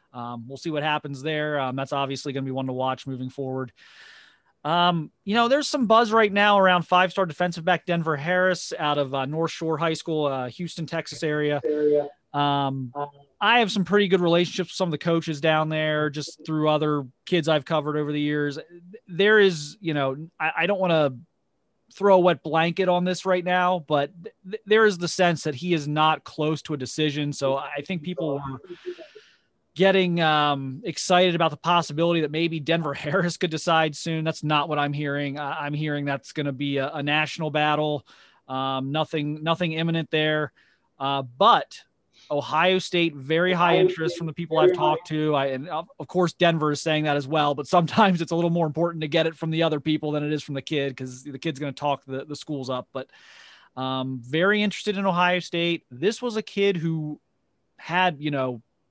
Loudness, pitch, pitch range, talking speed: -24 LUFS, 155 Hz, 145-175 Hz, 205 wpm